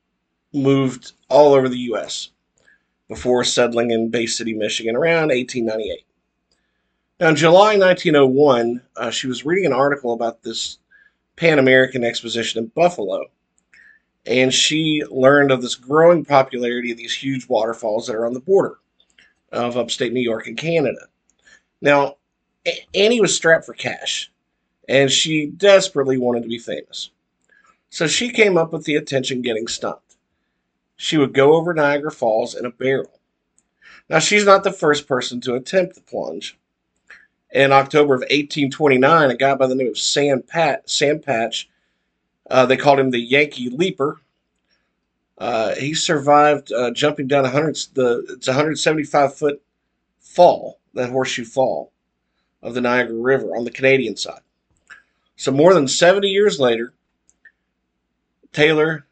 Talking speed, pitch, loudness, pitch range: 150 wpm, 135 Hz, -17 LUFS, 120-150 Hz